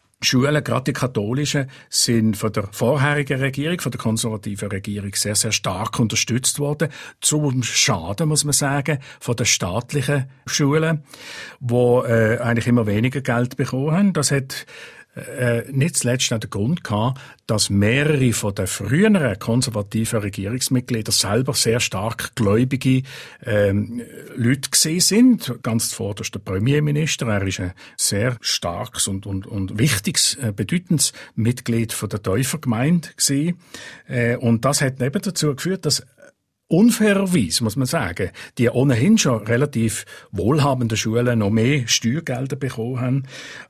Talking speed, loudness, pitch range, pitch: 135 wpm, -20 LUFS, 110-145 Hz, 125 Hz